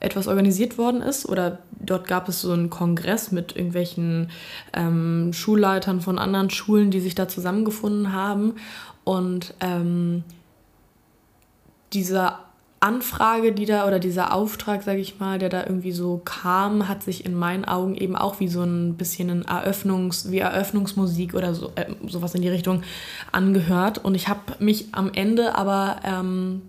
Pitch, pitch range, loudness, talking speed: 185 Hz, 180-200 Hz, -23 LUFS, 160 wpm